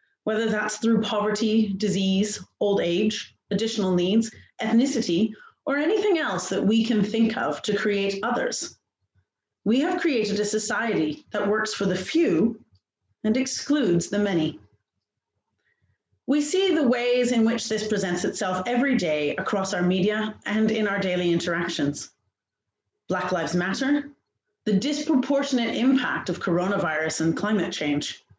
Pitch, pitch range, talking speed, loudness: 210 Hz, 175-235 Hz, 135 wpm, -24 LUFS